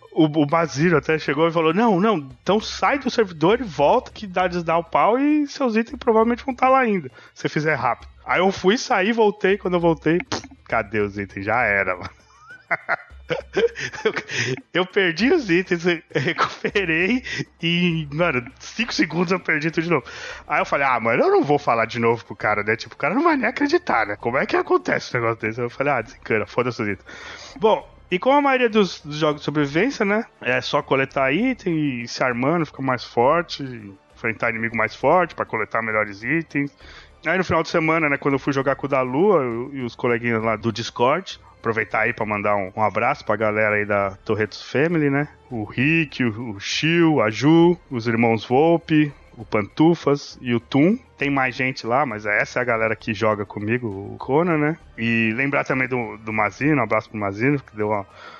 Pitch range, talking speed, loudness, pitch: 115-180 Hz, 205 wpm, -21 LUFS, 145 Hz